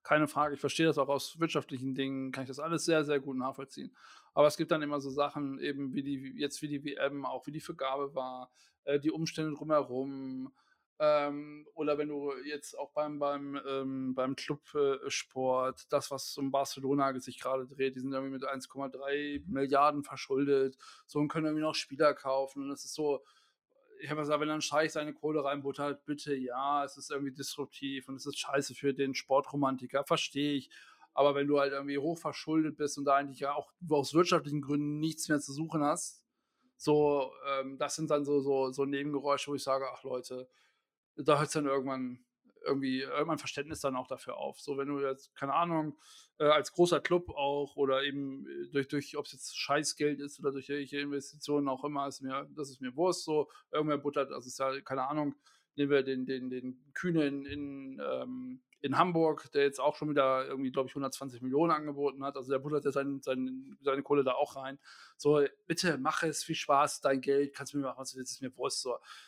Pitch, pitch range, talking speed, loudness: 140 Hz, 135-150 Hz, 205 wpm, -33 LUFS